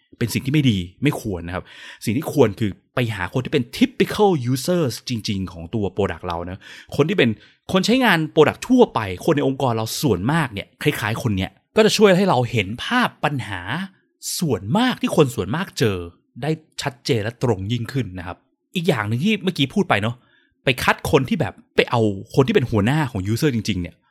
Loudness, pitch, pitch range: -20 LUFS, 130 Hz, 105-165 Hz